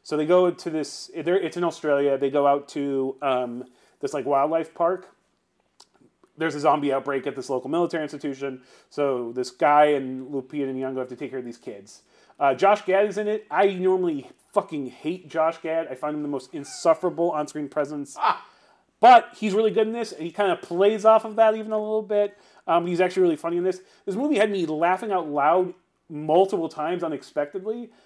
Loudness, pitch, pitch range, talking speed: -24 LUFS, 165 Hz, 145-195 Hz, 205 wpm